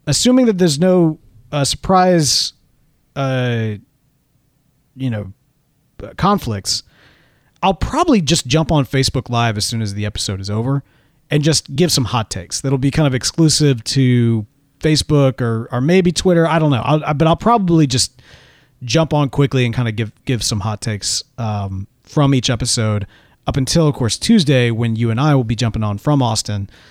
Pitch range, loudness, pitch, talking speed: 115-150 Hz, -16 LUFS, 135 Hz, 180 wpm